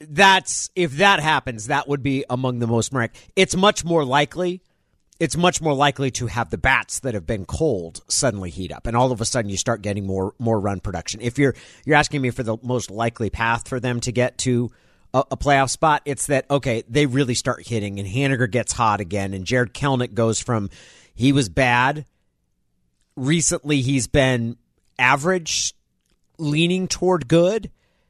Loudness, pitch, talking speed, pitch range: -21 LUFS, 125 Hz, 190 wpm, 115-145 Hz